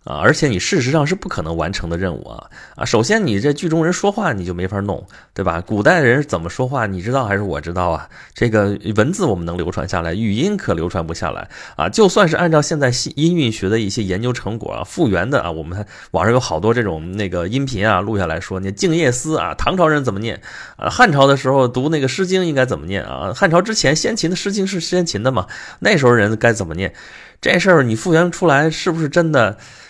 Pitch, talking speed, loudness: 115 Hz, 345 characters per minute, -17 LUFS